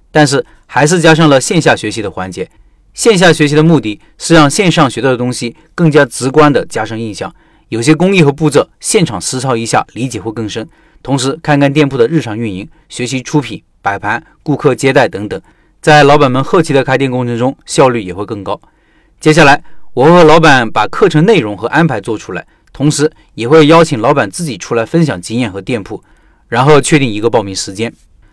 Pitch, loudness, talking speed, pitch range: 140 Hz, -10 LUFS, 305 characters per minute, 115-155 Hz